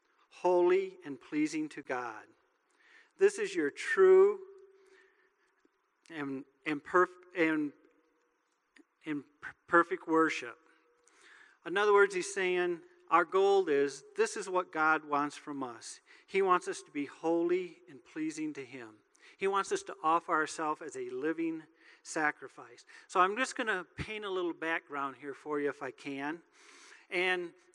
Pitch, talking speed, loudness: 190 Hz, 145 wpm, -32 LUFS